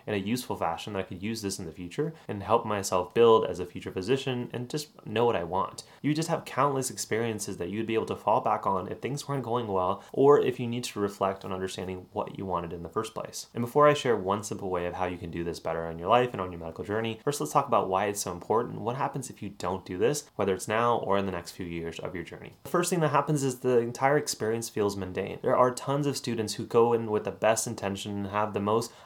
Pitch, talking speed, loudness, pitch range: 110 Hz, 280 wpm, -29 LUFS, 95-125 Hz